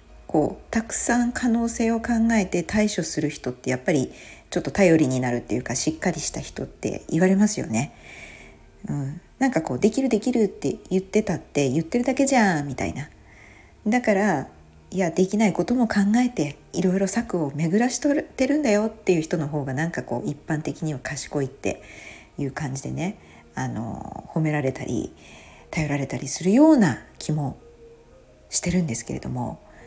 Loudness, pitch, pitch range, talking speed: -23 LUFS, 165 Hz, 135-215 Hz, 350 characters per minute